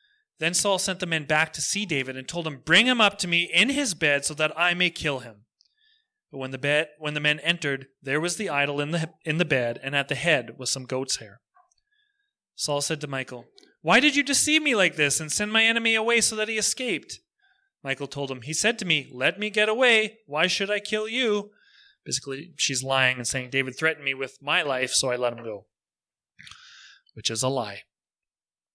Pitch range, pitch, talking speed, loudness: 135-215 Hz, 160 Hz, 225 wpm, -24 LUFS